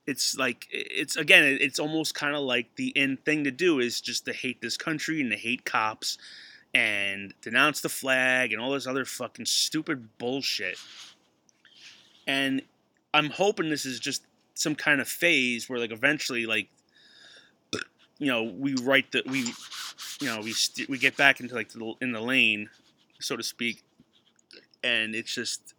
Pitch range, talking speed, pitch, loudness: 115-140 Hz, 175 wpm, 130 Hz, -26 LUFS